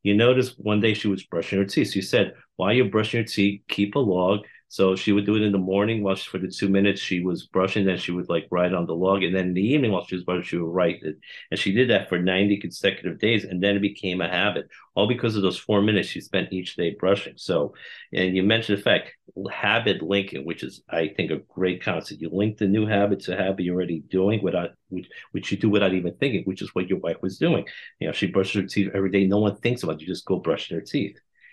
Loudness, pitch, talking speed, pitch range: -24 LUFS, 100 Hz, 270 wpm, 95-105 Hz